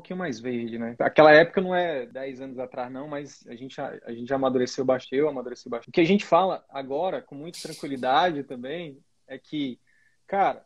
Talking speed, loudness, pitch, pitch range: 210 wpm, -24 LUFS, 140 Hz, 130-170 Hz